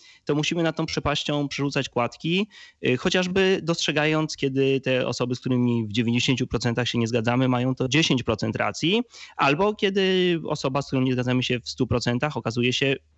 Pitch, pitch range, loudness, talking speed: 135 Hz, 125-160 Hz, -24 LUFS, 160 wpm